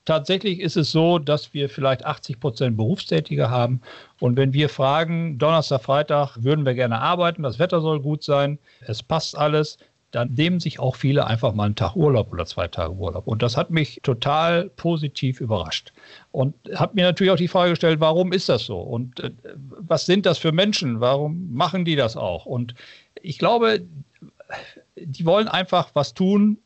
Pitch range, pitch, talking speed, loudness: 130-175 Hz, 150 Hz, 180 wpm, -21 LUFS